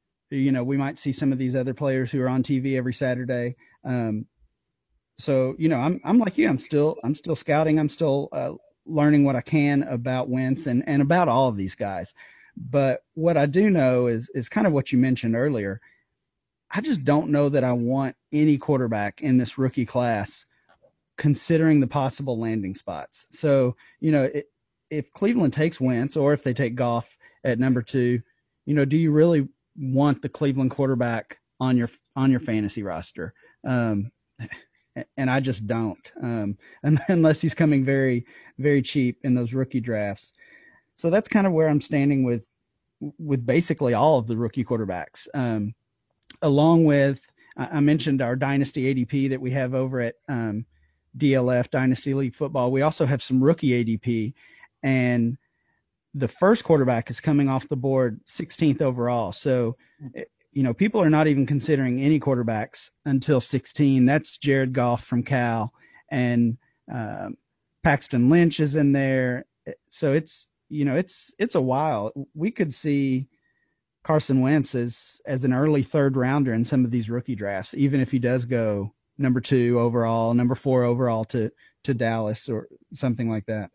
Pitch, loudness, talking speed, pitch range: 130 Hz, -23 LUFS, 170 wpm, 120-145 Hz